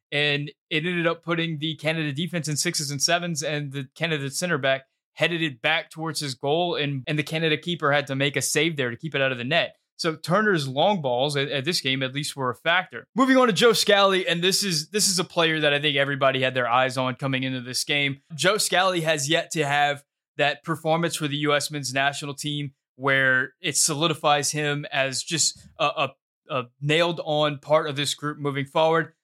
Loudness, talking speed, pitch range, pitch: -23 LUFS, 225 wpm, 140-165 Hz, 150 Hz